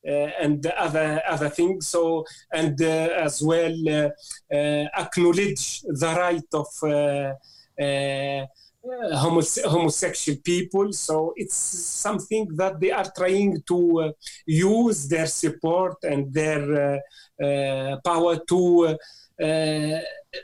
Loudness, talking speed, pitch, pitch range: -23 LUFS, 120 wpm, 160 Hz, 150-180 Hz